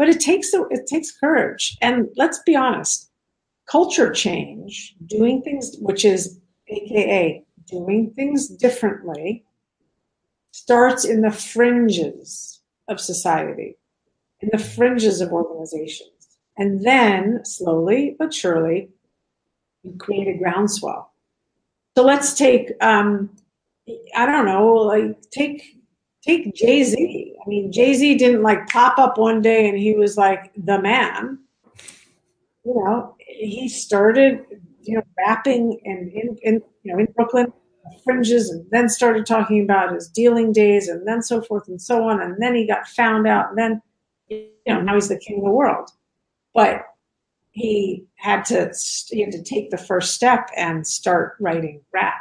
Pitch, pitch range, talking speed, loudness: 220 Hz, 195-245 Hz, 150 wpm, -19 LUFS